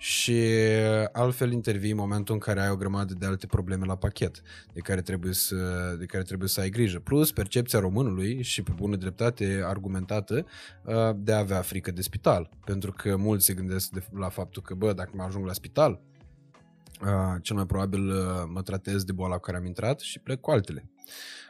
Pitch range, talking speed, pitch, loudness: 95-110 Hz, 190 wpm, 100 Hz, -28 LUFS